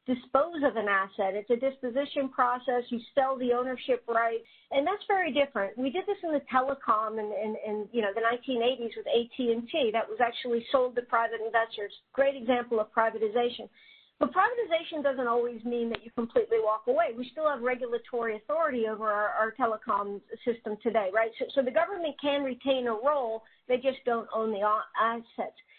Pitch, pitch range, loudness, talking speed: 240 Hz, 225-270 Hz, -29 LUFS, 190 wpm